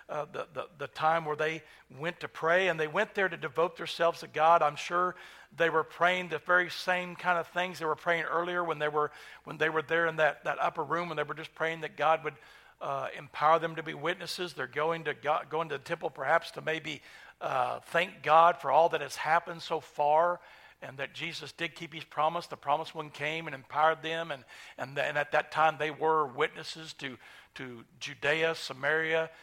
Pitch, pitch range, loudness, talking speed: 160 Hz, 150-170 Hz, -30 LUFS, 220 wpm